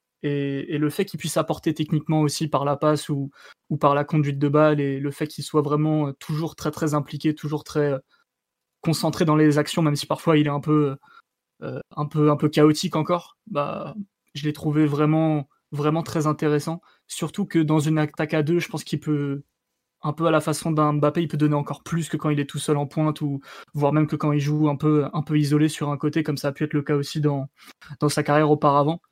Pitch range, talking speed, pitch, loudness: 145-160 Hz, 240 wpm, 150 Hz, -23 LUFS